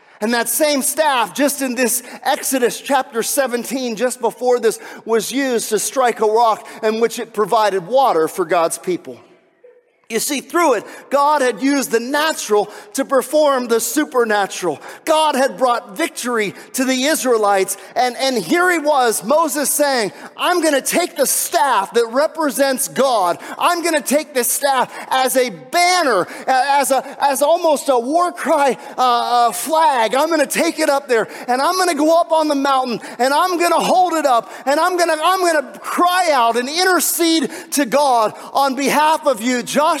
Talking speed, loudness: 175 wpm, -16 LUFS